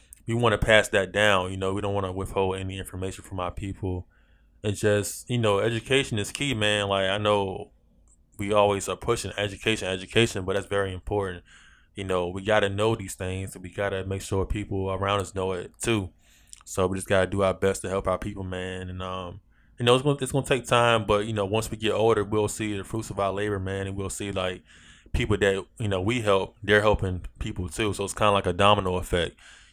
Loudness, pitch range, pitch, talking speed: -26 LUFS, 95-105 Hz, 100 Hz, 235 wpm